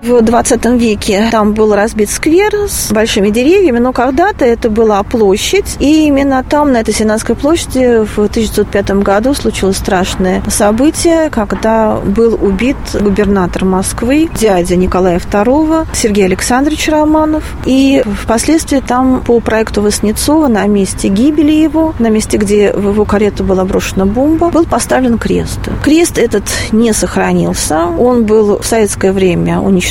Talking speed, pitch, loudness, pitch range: 140 wpm, 225 Hz, -10 LUFS, 205-275 Hz